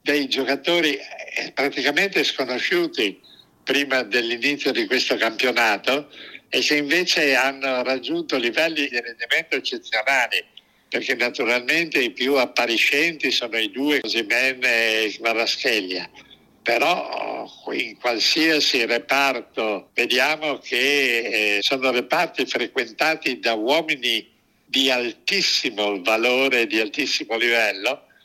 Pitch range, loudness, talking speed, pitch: 115-145 Hz, -20 LUFS, 100 wpm, 130 Hz